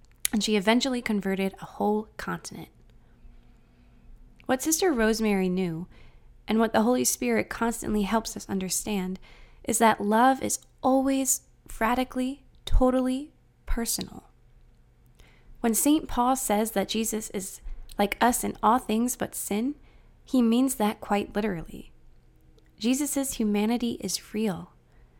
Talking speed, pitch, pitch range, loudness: 120 wpm, 220 Hz, 200-250 Hz, -26 LUFS